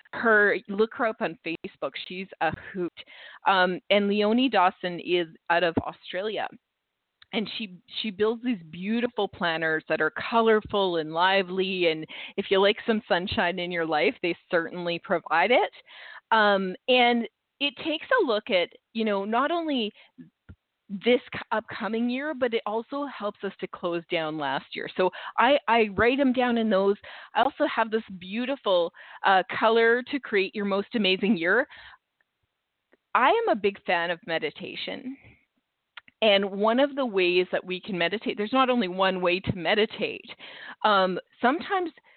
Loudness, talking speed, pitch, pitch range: -25 LUFS, 160 wpm, 205 Hz, 185-240 Hz